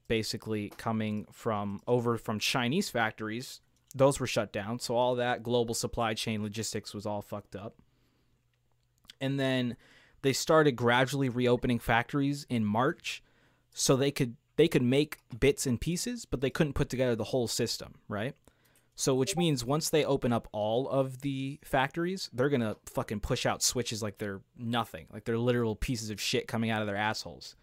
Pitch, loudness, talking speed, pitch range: 120 Hz, -31 LUFS, 175 wpm, 110-135 Hz